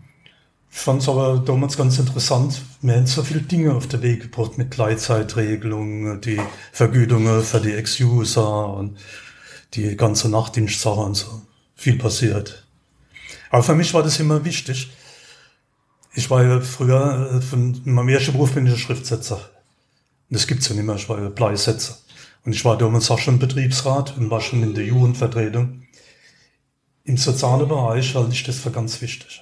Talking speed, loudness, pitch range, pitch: 165 wpm, -19 LUFS, 110-130 Hz, 125 Hz